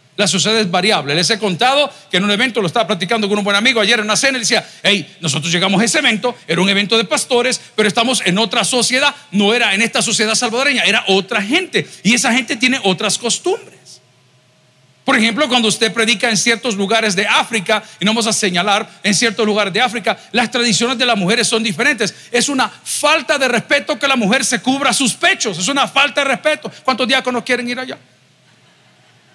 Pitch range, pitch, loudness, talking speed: 205-255 Hz, 230 Hz, -14 LUFS, 215 wpm